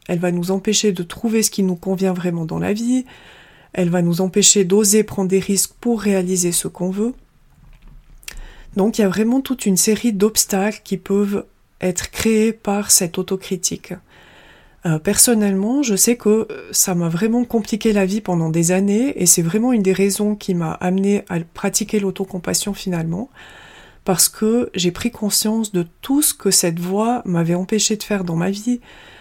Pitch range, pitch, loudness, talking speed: 185-215 Hz, 200 Hz, -18 LUFS, 180 wpm